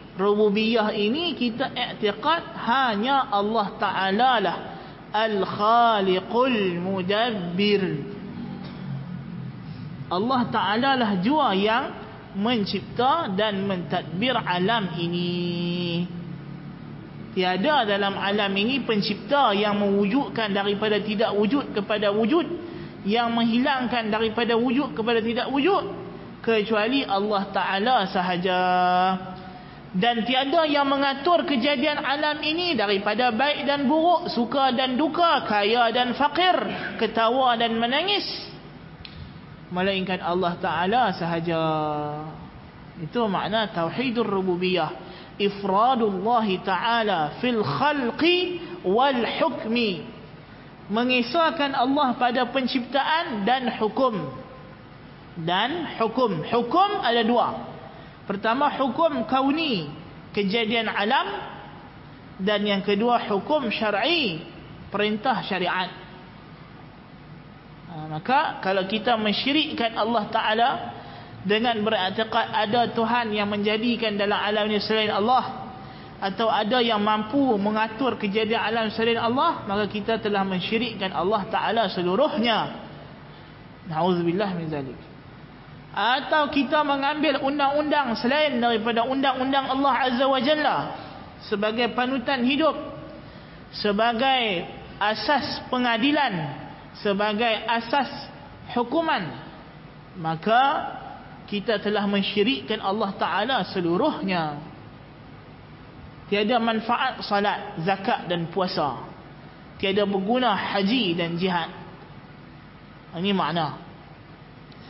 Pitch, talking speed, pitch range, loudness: 215 Hz, 90 wpm, 185-250 Hz, -23 LUFS